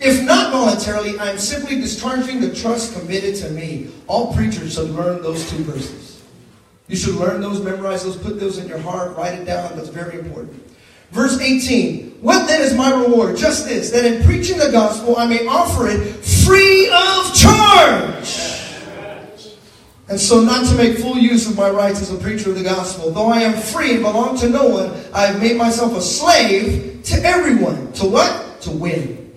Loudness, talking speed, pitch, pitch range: -15 LUFS, 190 wpm, 220 Hz, 190-255 Hz